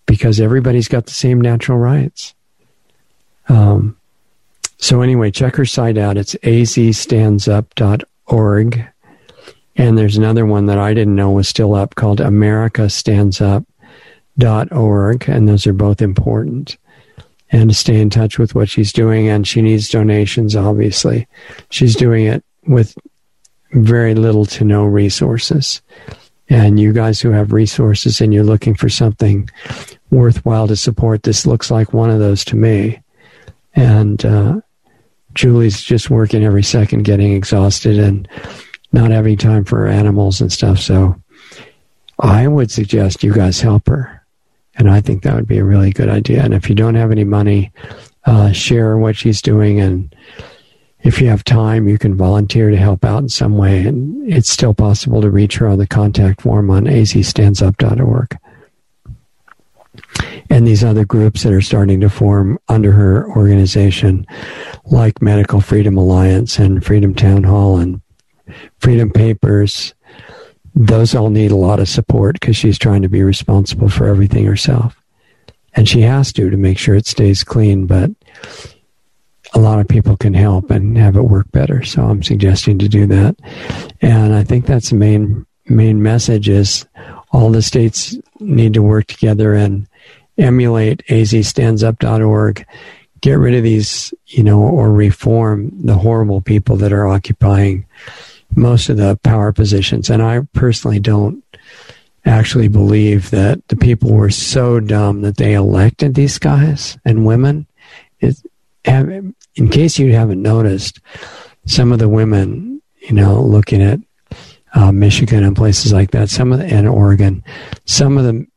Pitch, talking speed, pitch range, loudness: 110 Hz, 155 wpm, 100-120 Hz, -12 LUFS